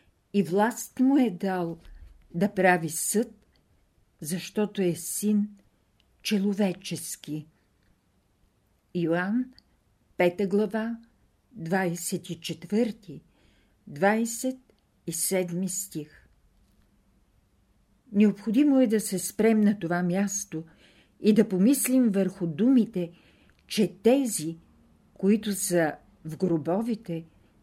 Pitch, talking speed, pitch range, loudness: 185 Hz, 80 wpm, 160-210 Hz, -26 LUFS